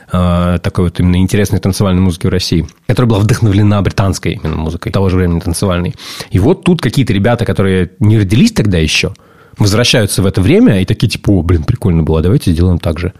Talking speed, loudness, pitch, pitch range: 195 wpm, -12 LUFS, 95 Hz, 90-110 Hz